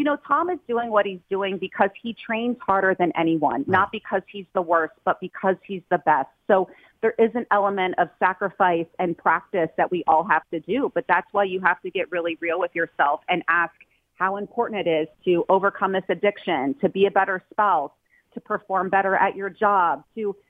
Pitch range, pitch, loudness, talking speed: 175-200 Hz, 190 Hz, -23 LUFS, 210 wpm